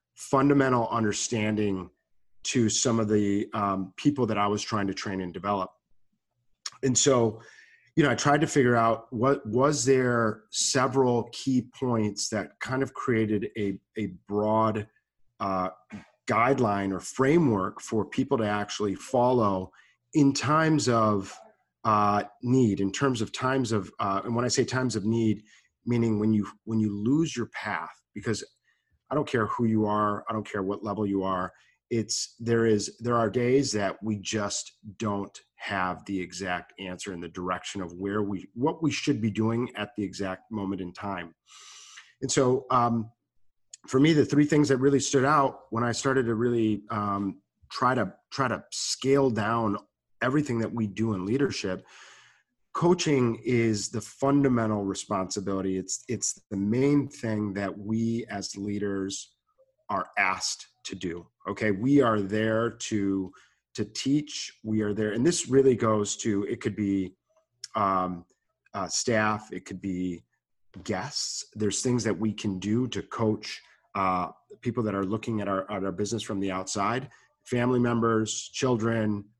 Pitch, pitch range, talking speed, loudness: 110 Hz, 100-125 Hz, 160 wpm, -27 LUFS